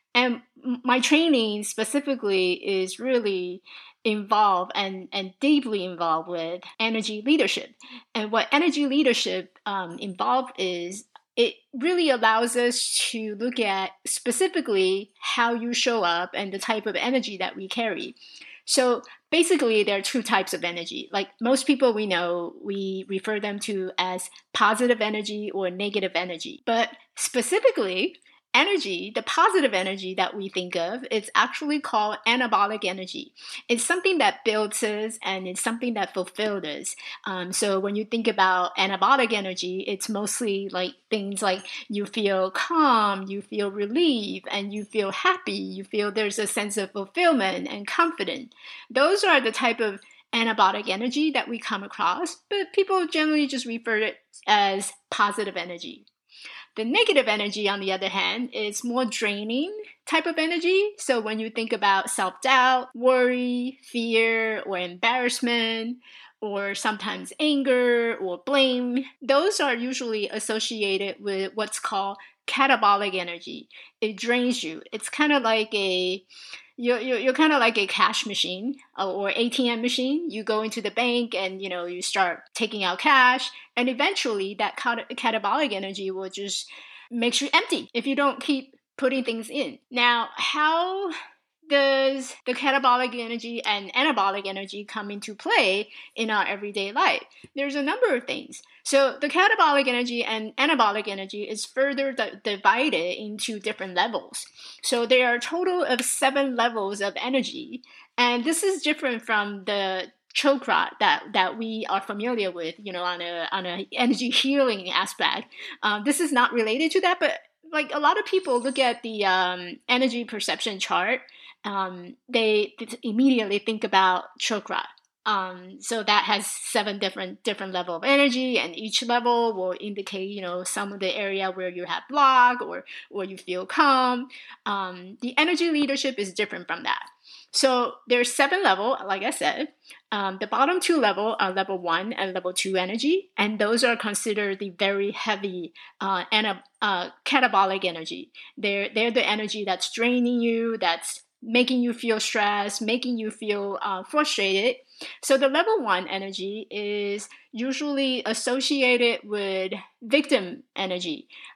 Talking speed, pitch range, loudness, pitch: 155 wpm, 195-260 Hz, -24 LUFS, 225 Hz